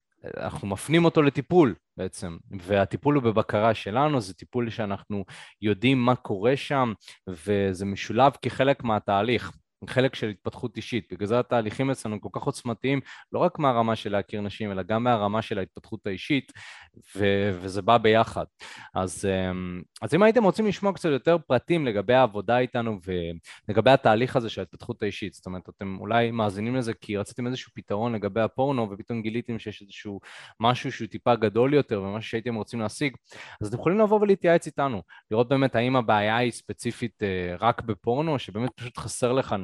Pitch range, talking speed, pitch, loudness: 100-130 Hz, 150 wpm, 115 Hz, -25 LUFS